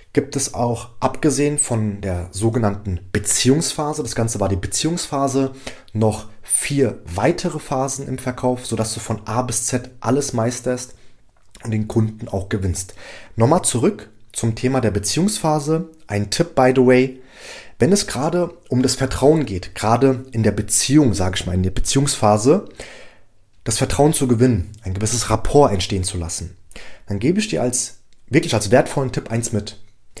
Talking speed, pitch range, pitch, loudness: 160 wpm, 105-135 Hz, 120 Hz, -19 LUFS